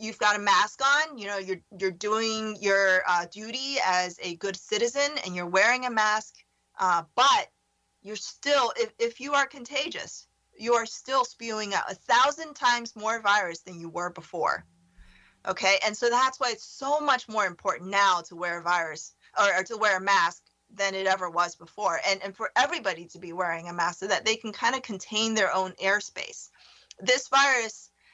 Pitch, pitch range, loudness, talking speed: 210 Hz, 185-245 Hz, -26 LUFS, 195 wpm